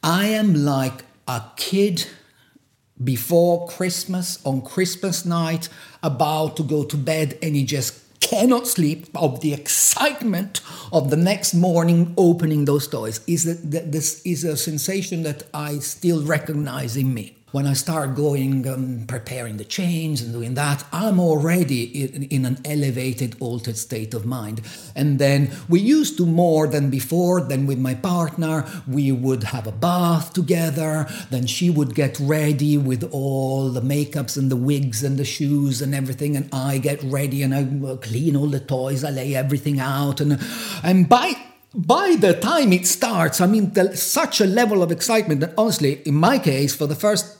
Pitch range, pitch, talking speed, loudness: 135-175 Hz, 150 Hz, 170 wpm, -20 LUFS